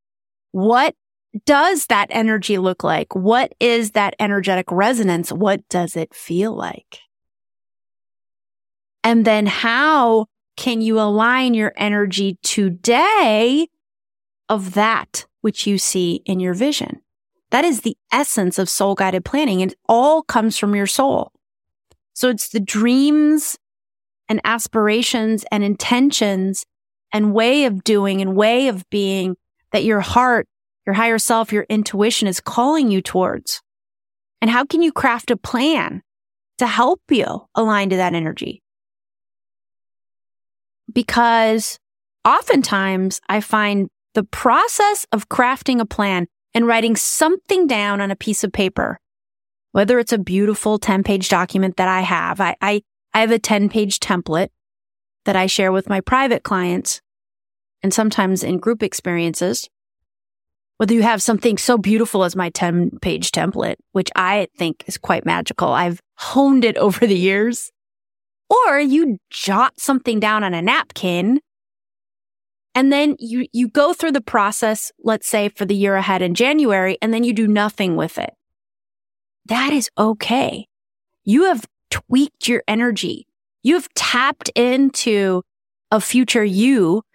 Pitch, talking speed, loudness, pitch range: 210 Hz, 140 wpm, -17 LUFS, 185-240 Hz